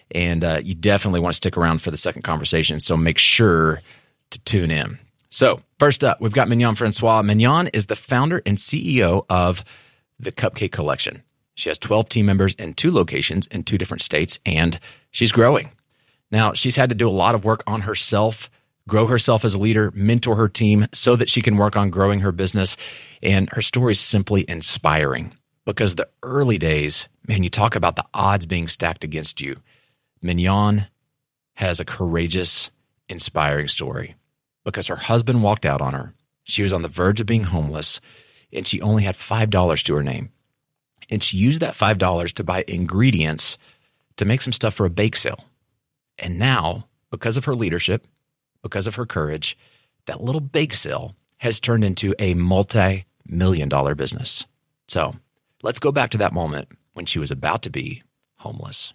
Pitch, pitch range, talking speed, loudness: 105 Hz, 90-120 Hz, 180 wpm, -20 LUFS